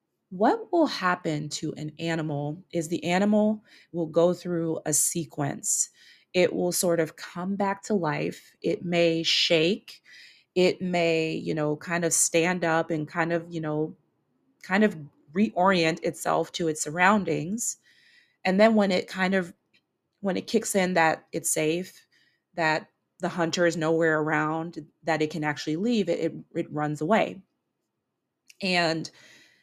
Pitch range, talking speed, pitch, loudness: 160-185 Hz, 150 wpm, 170 Hz, -26 LUFS